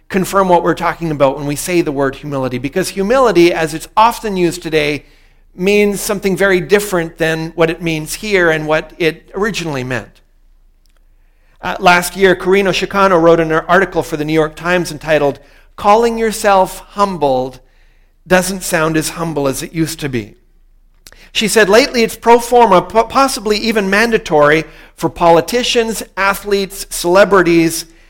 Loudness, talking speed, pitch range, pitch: -13 LUFS, 150 wpm, 155-195 Hz, 170 Hz